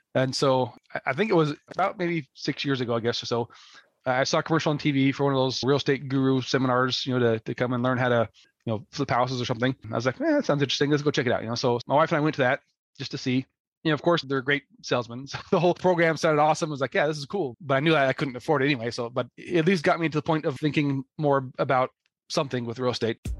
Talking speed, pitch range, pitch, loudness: 300 wpm, 125-155 Hz, 135 Hz, -25 LUFS